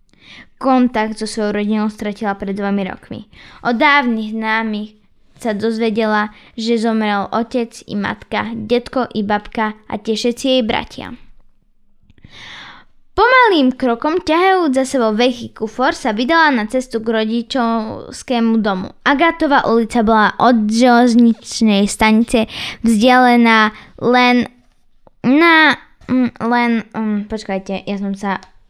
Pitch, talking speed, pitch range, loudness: 230 Hz, 115 wpm, 215-250 Hz, -15 LUFS